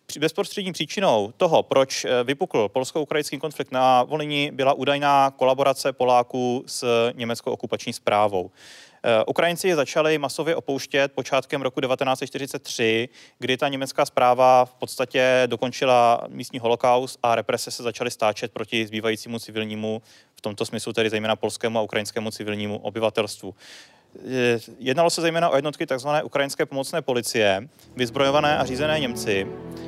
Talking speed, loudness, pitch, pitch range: 130 wpm, -23 LUFS, 130 Hz, 115-145 Hz